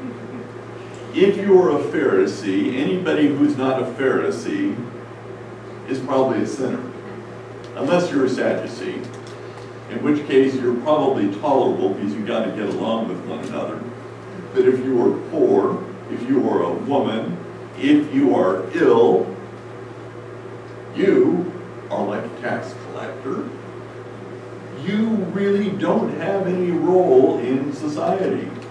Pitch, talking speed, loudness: 170 Hz, 130 wpm, -20 LUFS